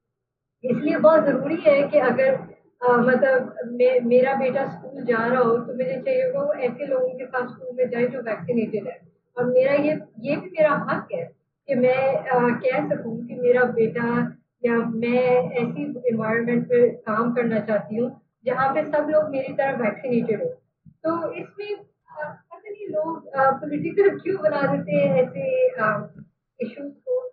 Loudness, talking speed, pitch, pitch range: -22 LUFS, 160 wpm, 255 Hz, 235-285 Hz